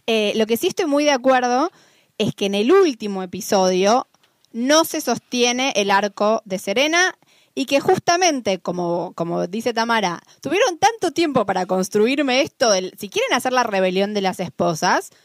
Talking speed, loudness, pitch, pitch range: 170 wpm, -19 LUFS, 230 Hz, 195-285 Hz